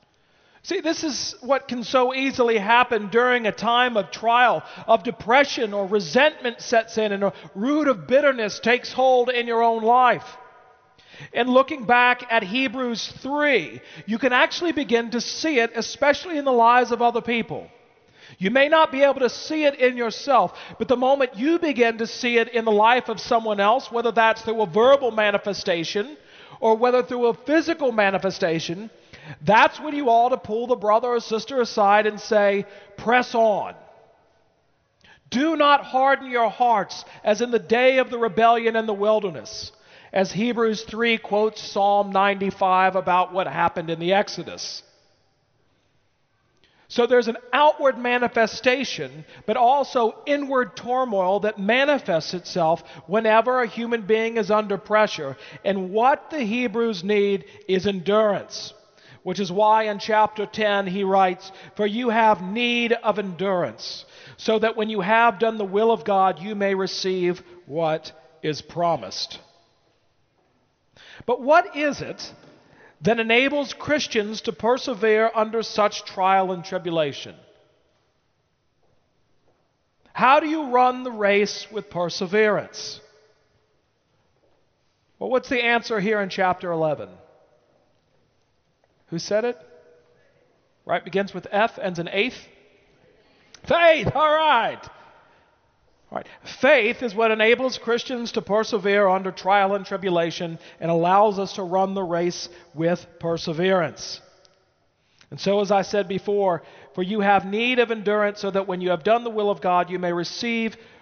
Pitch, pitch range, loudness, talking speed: 220 Hz, 195-245 Hz, -21 LUFS, 150 wpm